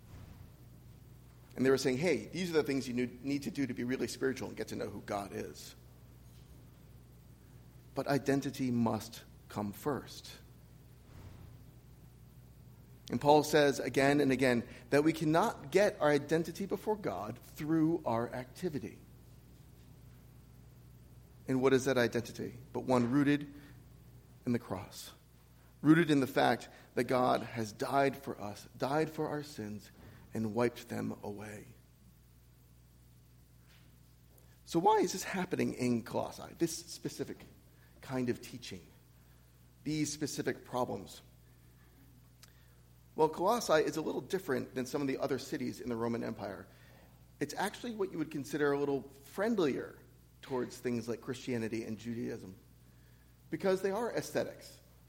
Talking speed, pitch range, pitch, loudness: 135 wpm, 100-140 Hz, 125 Hz, -34 LUFS